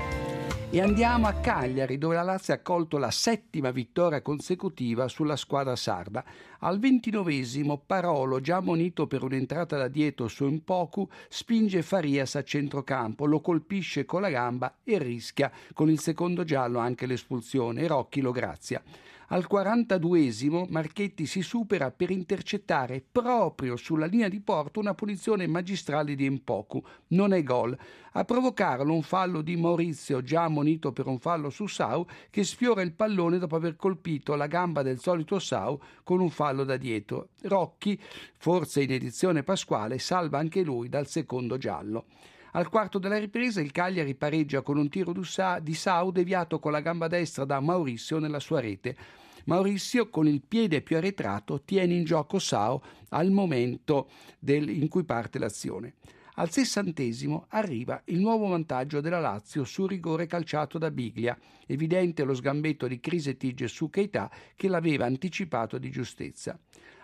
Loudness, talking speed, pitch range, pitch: -29 LUFS, 155 wpm, 135-185 Hz, 160 Hz